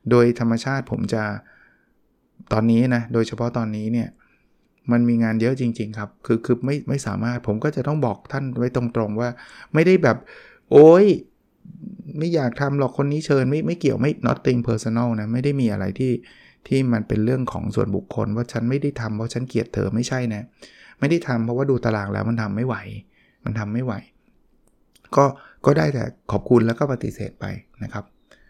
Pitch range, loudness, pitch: 115-135 Hz, -21 LUFS, 120 Hz